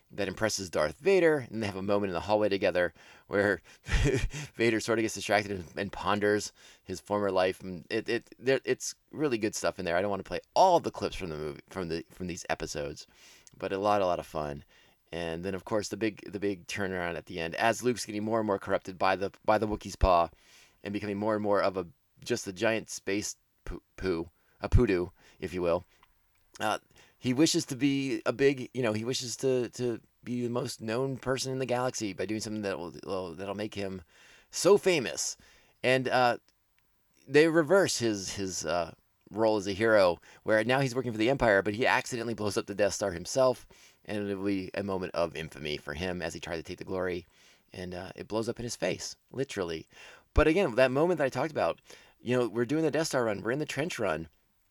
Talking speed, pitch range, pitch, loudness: 225 wpm, 95-125 Hz, 105 Hz, -30 LUFS